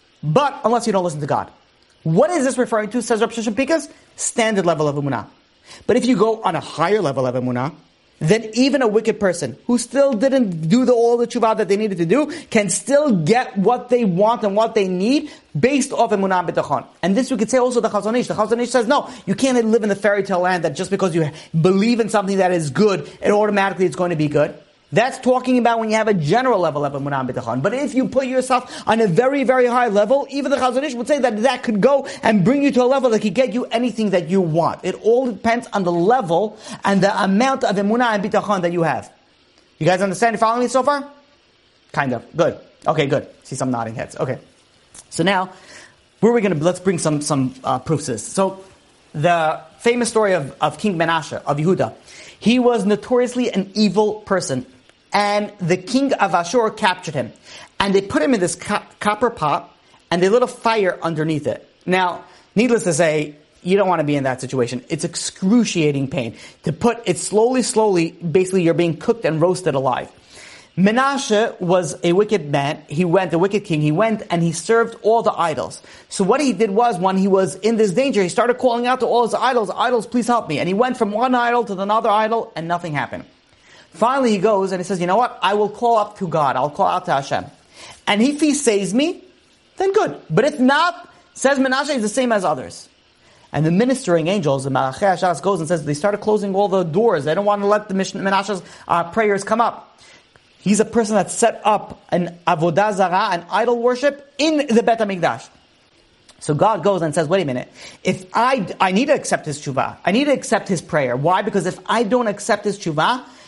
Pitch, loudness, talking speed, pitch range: 205 Hz, -18 LUFS, 220 wpm, 175-240 Hz